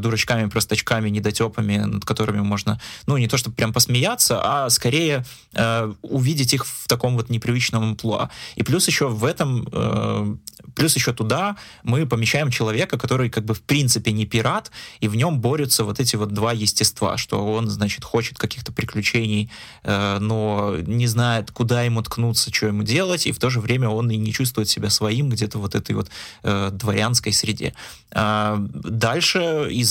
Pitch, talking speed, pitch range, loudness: 115 Hz, 175 wpm, 105-125 Hz, -21 LUFS